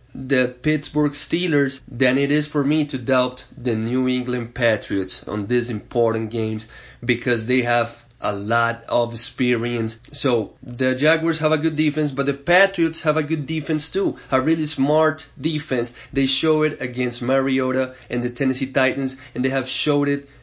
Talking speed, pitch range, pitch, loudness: 170 wpm, 120-150 Hz, 130 Hz, -21 LUFS